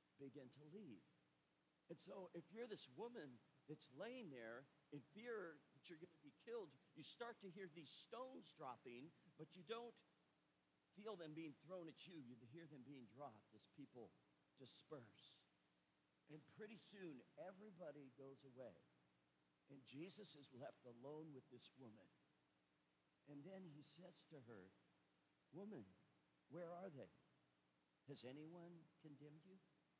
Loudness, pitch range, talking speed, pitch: -60 LUFS, 125-175 Hz, 145 wpm, 150 Hz